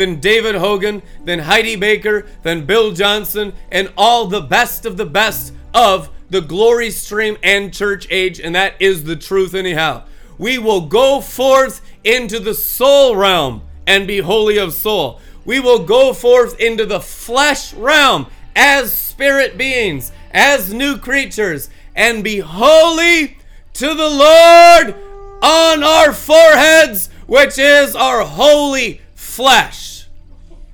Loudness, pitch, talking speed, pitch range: -12 LUFS, 220 Hz, 135 wpm, 195-280 Hz